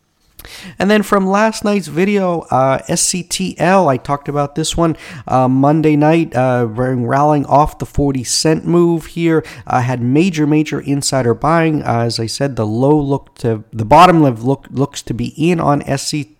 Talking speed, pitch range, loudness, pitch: 170 wpm, 130-165 Hz, -14 LUFS, 145 Hz